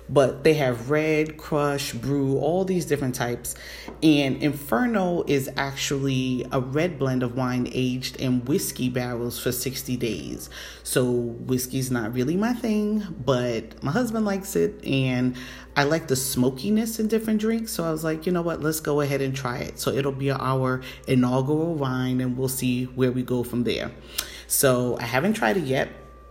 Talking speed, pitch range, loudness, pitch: 180 wpm, 125-155 Hz, -25 LUFS, 135 Hz